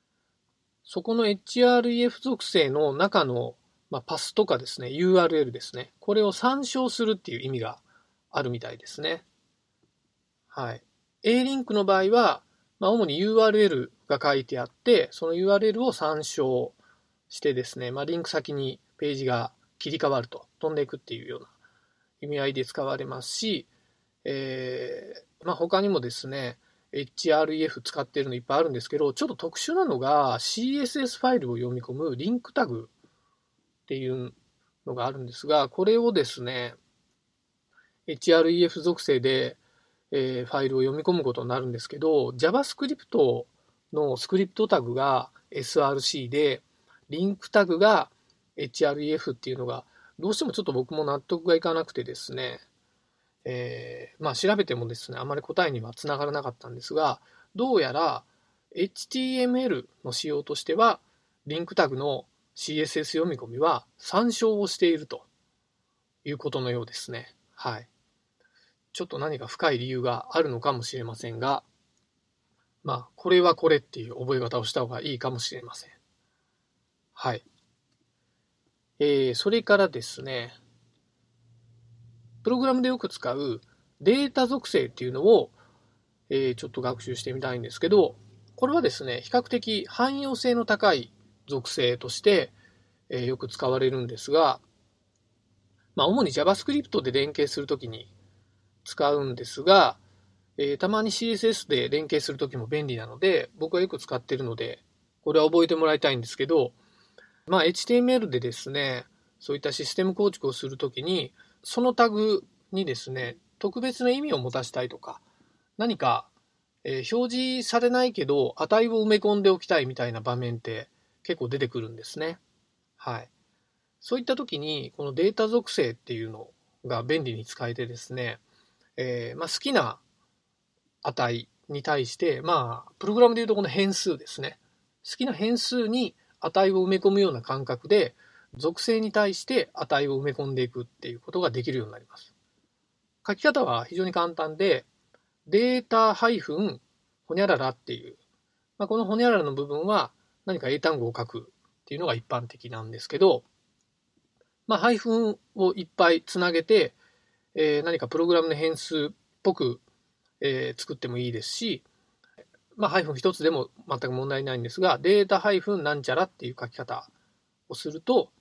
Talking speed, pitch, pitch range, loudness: 320 characters per minute, 155 Hz, 125-210 Hz, -26 LUFS